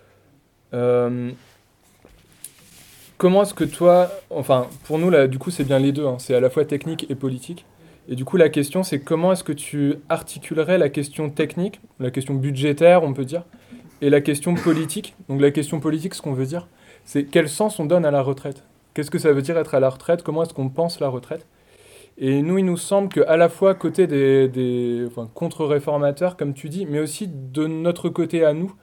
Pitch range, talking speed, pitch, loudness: 140-175 Hz, 210 wpm, 155 Hz, -20 LUFS